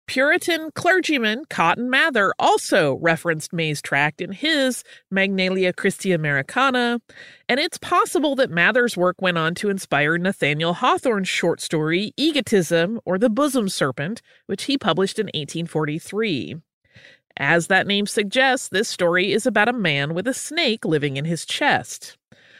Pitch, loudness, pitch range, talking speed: 200 Hz, -20 LUFS, 170-260 Hz, 145 wpm